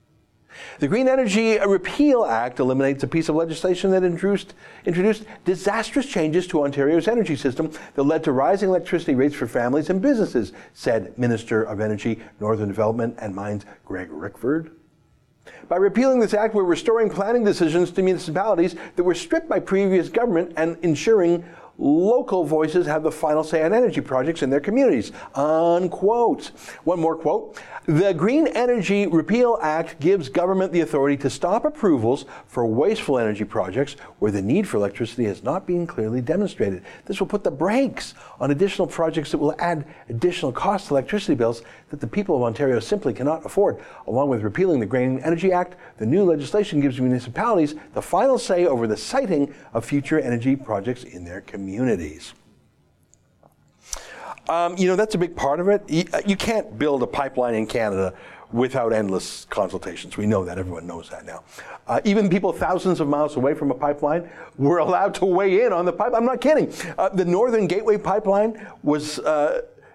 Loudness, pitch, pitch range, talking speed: -22 LUFS, 170 Hz, 140-200 Hz, 170 wpm